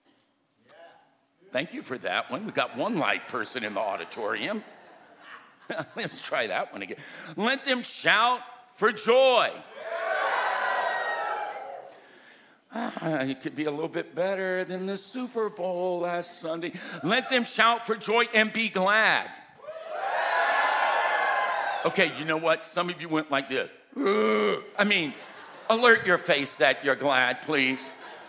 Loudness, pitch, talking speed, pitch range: -26 LUFS, 195 Hz, 135 wpm, 165-245 Hz